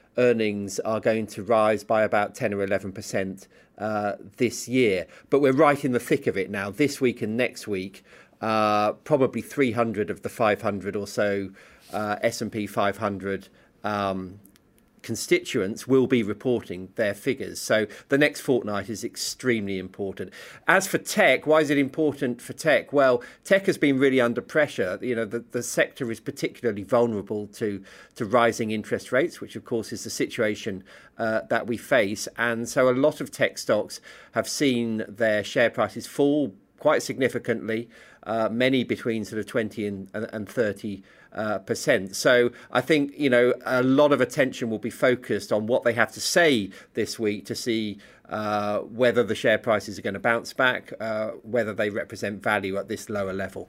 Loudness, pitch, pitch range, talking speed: -25 LUFS, 115 Hz, 105-125 Hz, 175 wpm